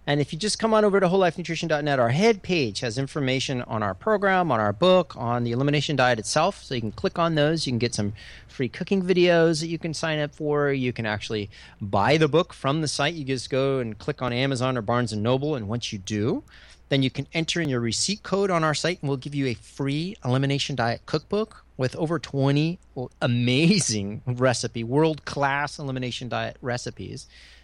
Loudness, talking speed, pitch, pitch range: -24 LUFS, 210 wpm, 135 Hz, 120-160 Hz